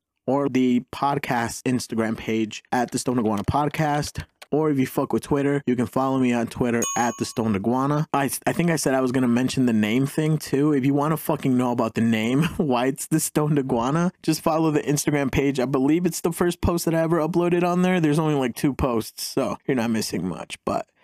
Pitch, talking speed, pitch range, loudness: 140 Hz, 235 wpm, 125-155 Hz, -23 LUFS